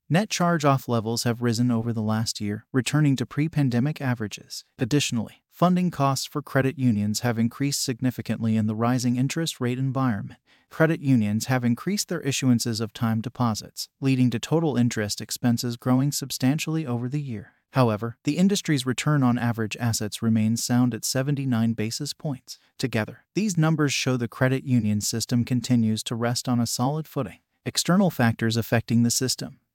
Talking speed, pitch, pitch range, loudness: 165 wpm, 125 Hz, 115-140 Hz, -24 LUFS